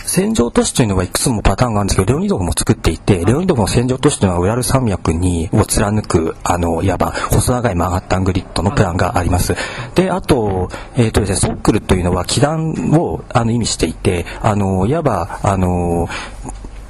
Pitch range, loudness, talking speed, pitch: 90-125 Hz, -16 LUFS, 425 characters per minute, 100 Hz